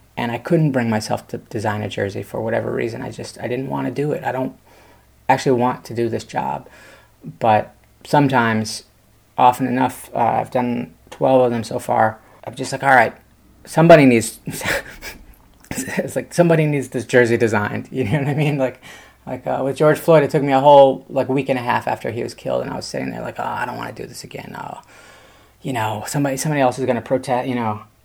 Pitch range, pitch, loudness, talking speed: 115-135 Hz, 125 Hz, -18 LUFS, 225 wpm